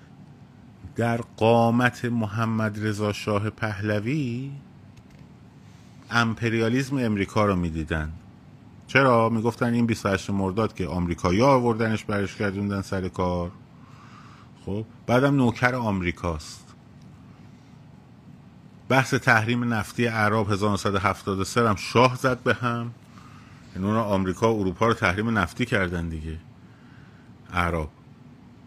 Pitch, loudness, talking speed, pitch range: 110 Hz, -24 LUFS, 100 wpm, 95-120 Hz